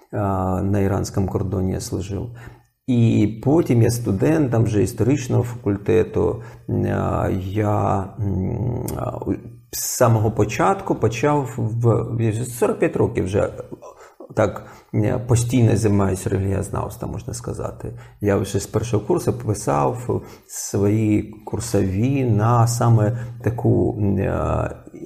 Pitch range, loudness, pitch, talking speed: 100-120 Hz, -21 LUFS, 110 Hz, 95 wpm